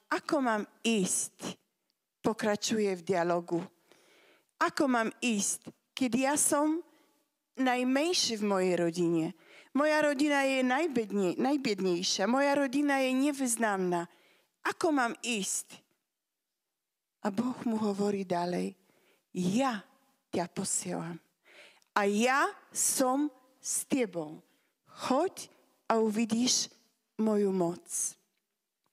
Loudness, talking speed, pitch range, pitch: -30 LUFS, 95 wpm, 195-275 Hz, 230 Hz